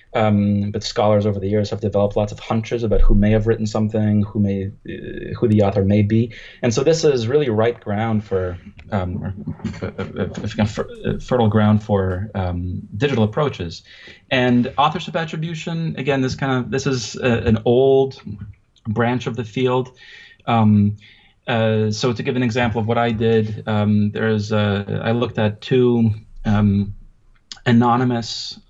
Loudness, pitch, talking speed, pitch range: -19 LUFS, 110 Hz, 165 wpm, 105-125 Hz